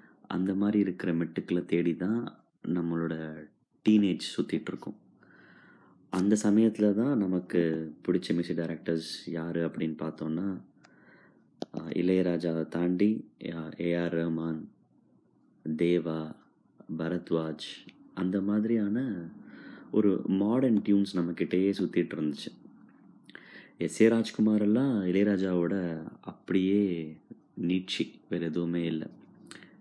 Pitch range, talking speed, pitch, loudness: 80-100 Hz, 85 wpm, 85 Hz, -30 LUFS